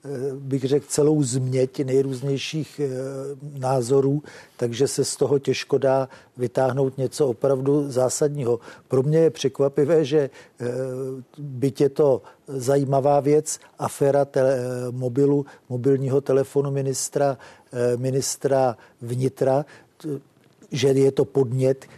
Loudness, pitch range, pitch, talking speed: -23 LUFS, 130-140 Hz, 135 Hz, 100 wpm